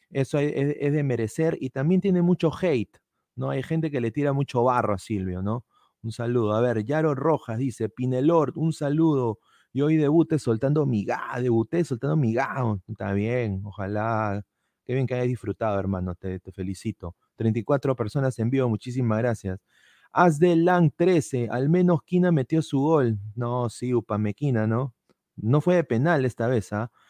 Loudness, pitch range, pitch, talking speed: -25 LUFS, 110-150 Hz, 125 Hz, 175 wpm